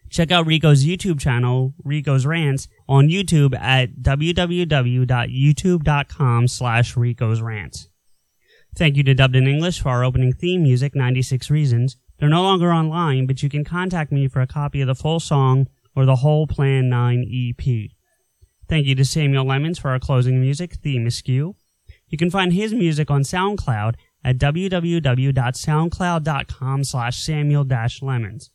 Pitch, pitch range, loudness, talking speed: 135 Hz, 130-155 Hz, -19 LUFS, 150 wpm